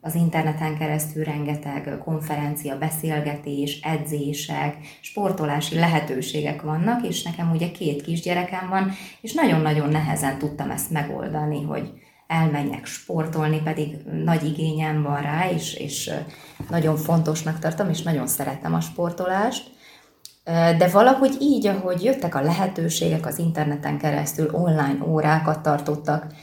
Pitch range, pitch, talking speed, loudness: 150-170 Hz, 155 Hz, 120 wpm, -23 LUFS